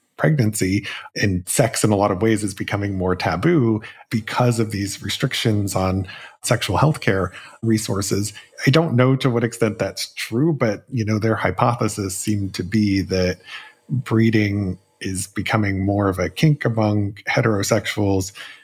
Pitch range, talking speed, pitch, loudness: 95-115 Hz, 150 wpm, 105 Hz, -20 LUFS